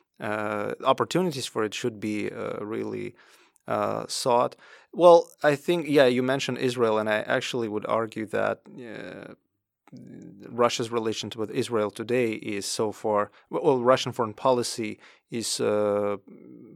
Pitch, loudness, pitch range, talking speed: 115 Hz, -26 LUFS, 105-130 Hz, 140 wpm